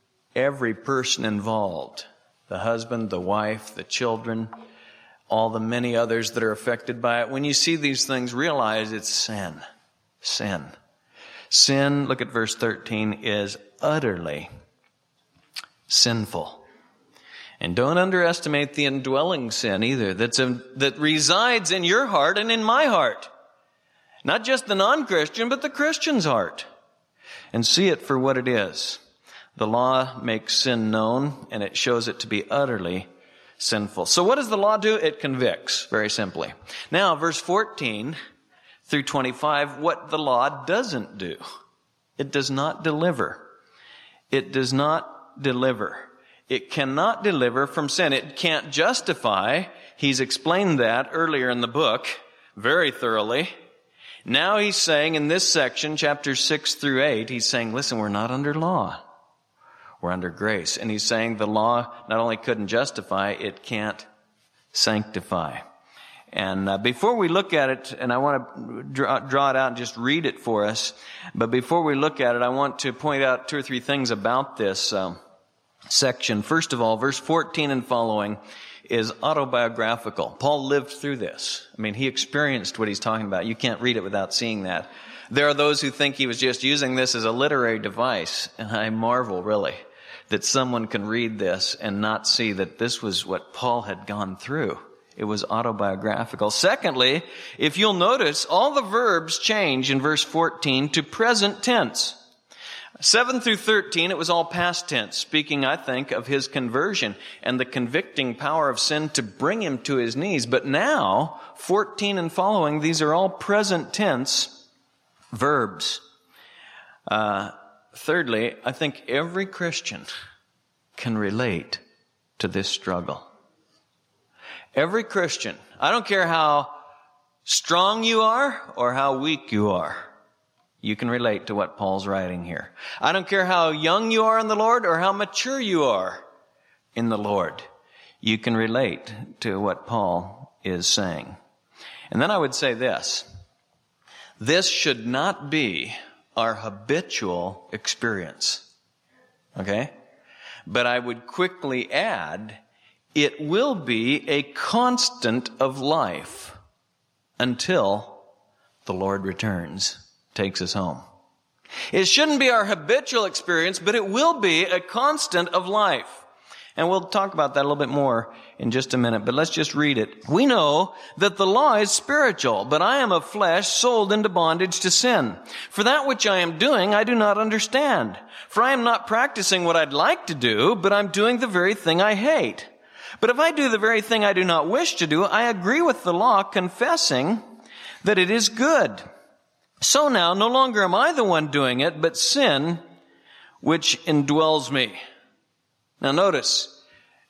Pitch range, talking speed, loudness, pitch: 115-185 Hz, 160 wpm, -22 LUFS, 140 Hz